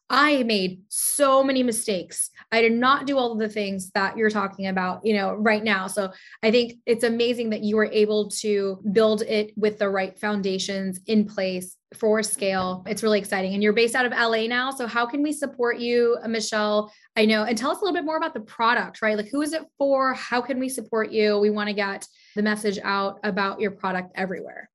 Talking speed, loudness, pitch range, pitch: 225 wpm, -23 LUFS, 200-240 Hz, 215 Hz